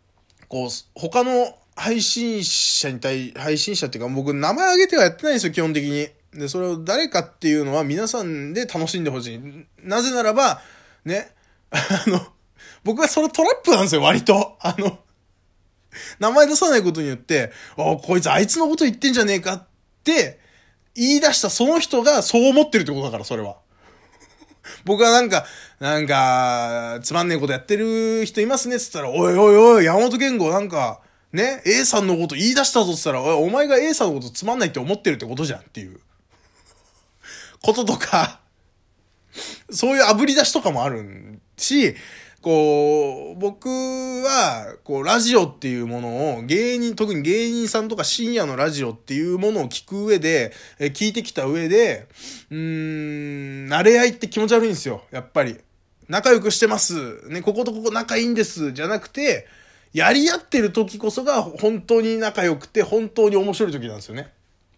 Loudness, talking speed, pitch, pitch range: -19 LUFS, 355 characters per minute, 195 Hz, 145-235 Hz